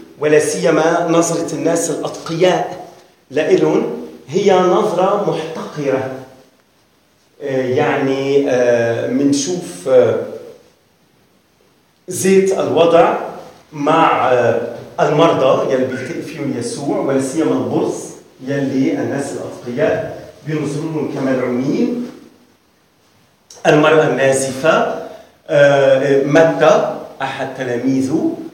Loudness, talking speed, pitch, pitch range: -15 LUFS, 65 wpm, 155 Hz, 135-175 Hz